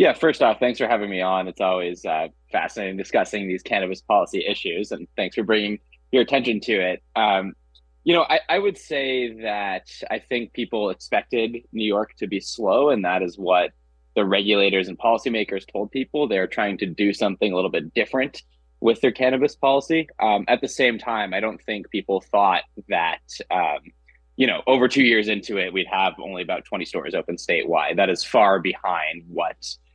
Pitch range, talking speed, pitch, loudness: 90-125 Hz, 195 wpm, 105 Hz, -22 LUFS